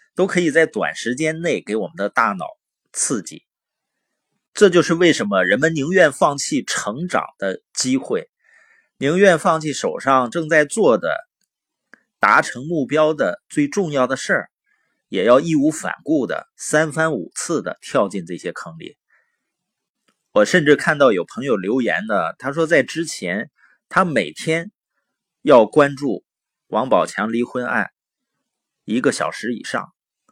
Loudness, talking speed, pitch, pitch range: -18 LUFS, 210 characters per minute, 165 Hz, 145-205 Hz